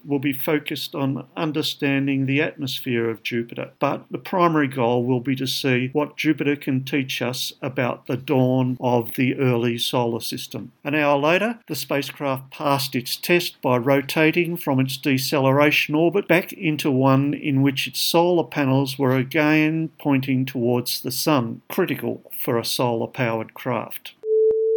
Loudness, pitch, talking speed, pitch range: -22 LUFS, 140 Hz, 155 wpm, 130-155 Hz